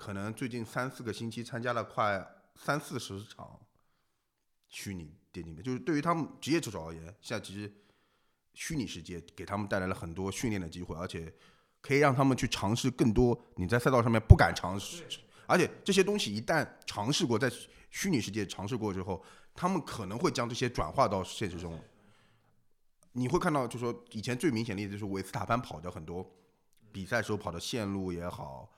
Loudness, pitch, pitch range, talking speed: -32 LUFS, 105 Hz, 95-125 Hz, 300 characters per minute